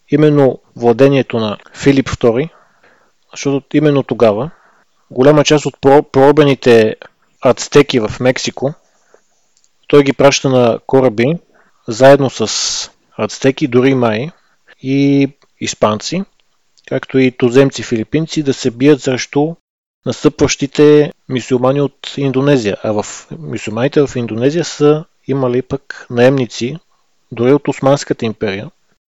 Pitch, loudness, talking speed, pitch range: 135 Hz, -13 LUFS, 105 wpm, 125-145 Hz